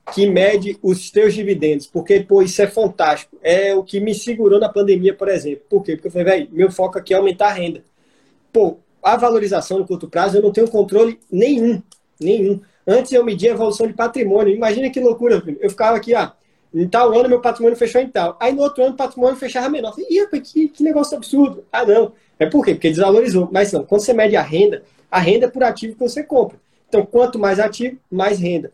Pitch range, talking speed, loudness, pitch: 195-245 Hz, 225 wpm, -16 LUFS, 215 Hz